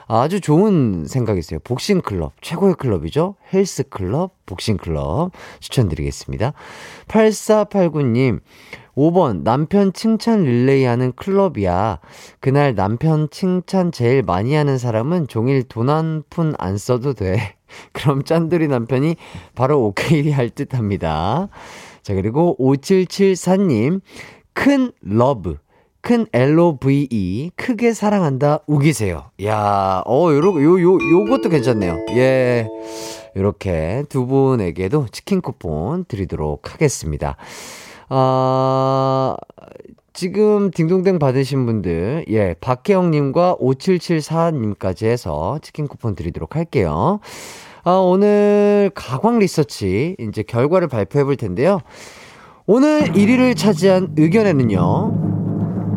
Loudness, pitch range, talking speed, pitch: -17 LUFS, 110-180 Hz, 235 characters per minute, 140 Hz